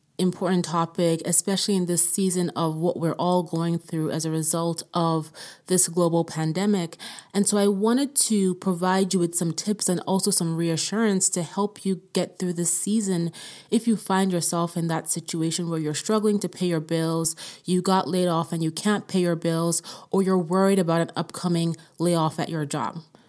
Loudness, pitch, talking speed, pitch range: -24 LUFS, 175 Hz, 190 wpm, 165-190 Hz